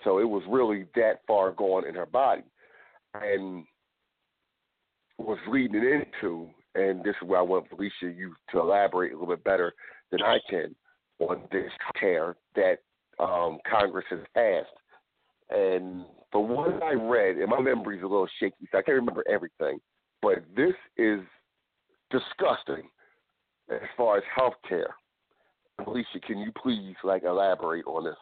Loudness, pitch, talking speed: -28 LUFS, 105 Hz, 155 wpm